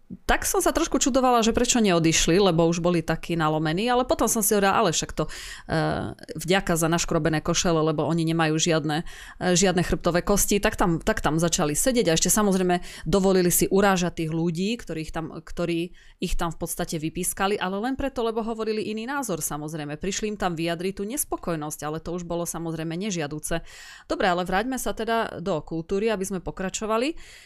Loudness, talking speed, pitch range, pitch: -24 LUFS, 190 wpm, 165-210 Hz, 180 Hz